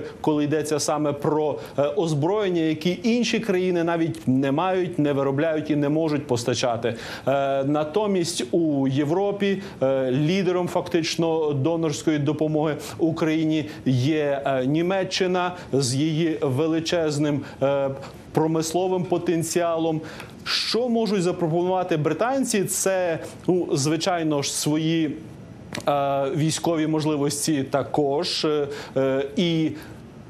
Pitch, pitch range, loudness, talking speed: 155 Hz, 145-175 Hz, -23 LUFS, 95 wpm